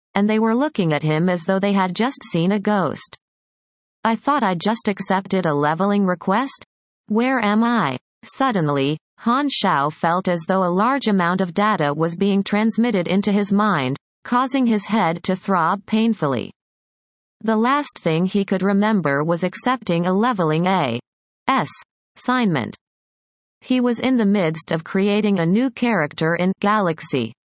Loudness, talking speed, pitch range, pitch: -20 LUFS, 160 wpm, 170-225 Hz, 200 Hz